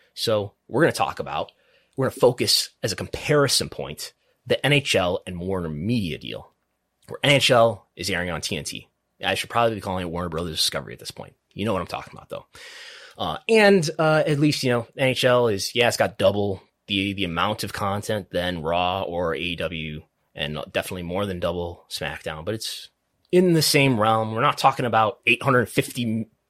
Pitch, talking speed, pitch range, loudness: 115 Hz, 190 wpm, 95-140 Hz, -22 LUFS